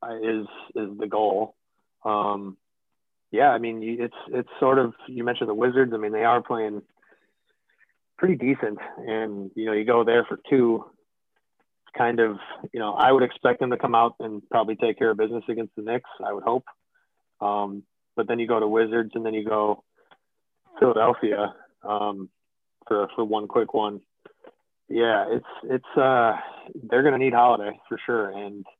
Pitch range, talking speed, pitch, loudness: 105-120 Hz, 175 wpm, 110 Hz, -24 LUFS